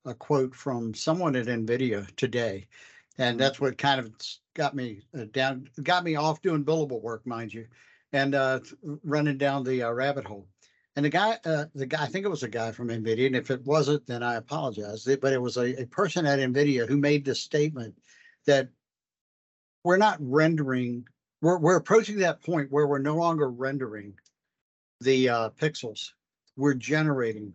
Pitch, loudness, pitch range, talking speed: 135 Hz, -27 LUFS, 120-150 Hz, 180 wpm